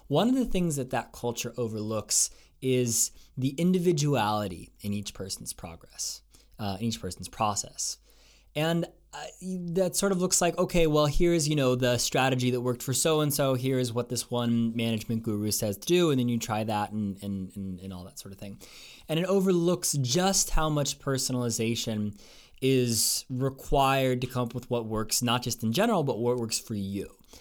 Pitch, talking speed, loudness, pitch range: 125 Hz, 190 wpm, -28 LUFS, 110-150 Hz